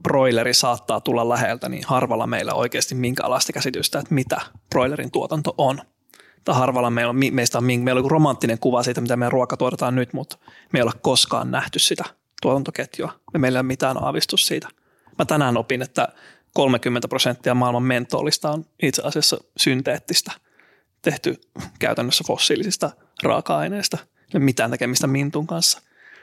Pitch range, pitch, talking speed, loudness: 125-140 Hz, 130 Hz, 160 wpm, -21 LUFS